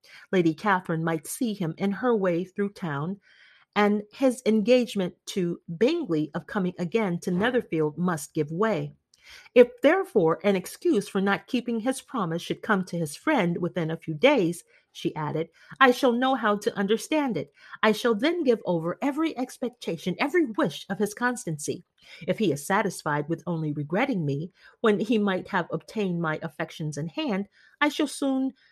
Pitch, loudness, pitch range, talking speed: 195 Hz, -26 LUFS, 170-245 Hz, 170 wpm